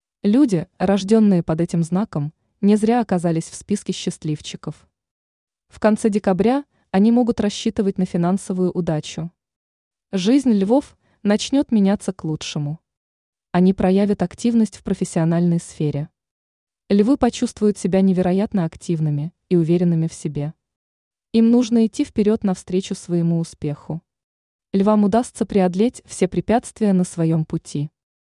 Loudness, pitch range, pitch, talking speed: -20 LUFS, 165-215 Hz, 190 Hz, 120 wpm